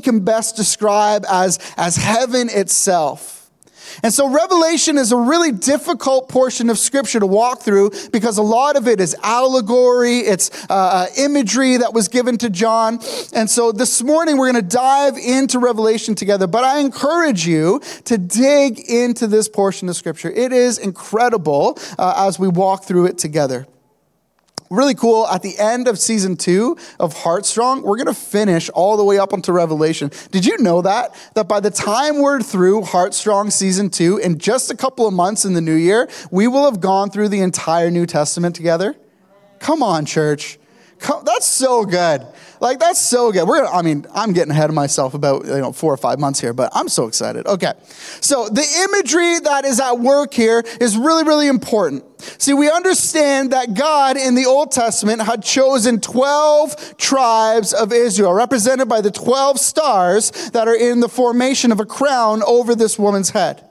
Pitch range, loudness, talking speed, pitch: 190-265 Hz, -15 LUFS, 185 wpm, 225 Hz